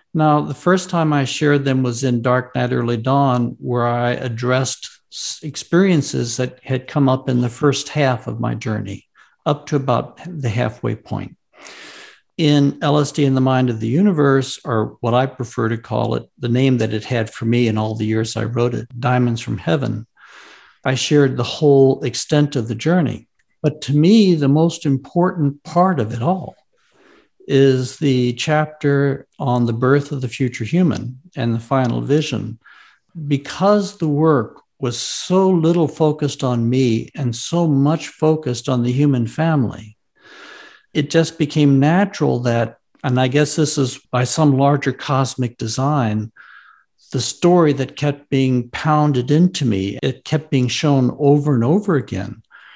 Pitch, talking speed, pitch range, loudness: 135 Hz, 165 wpm, 125-150 Hz, -18 LUFS